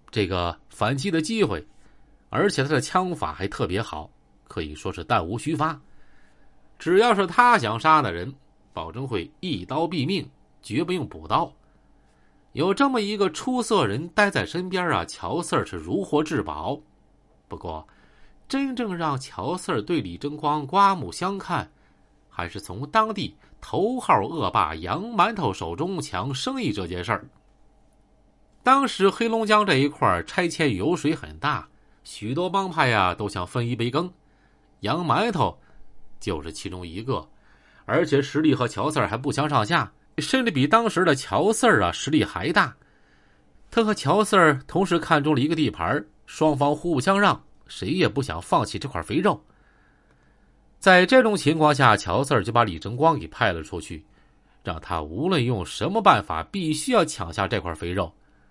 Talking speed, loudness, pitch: 235 characters per minute, -23 LUFS, 150 Hz